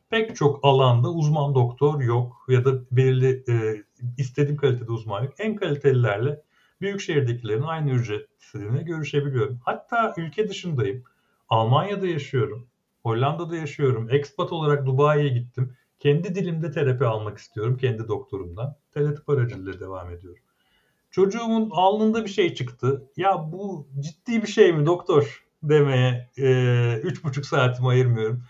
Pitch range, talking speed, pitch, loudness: 125-165 Hz, 130 wpm, 140 Hz, -23 LUFS